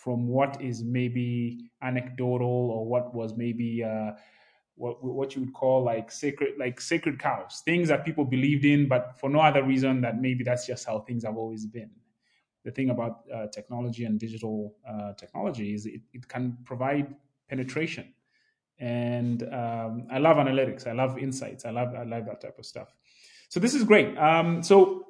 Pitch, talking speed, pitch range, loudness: 125 Hz, 180 wpm, 120-140 Hz, -27 LUFS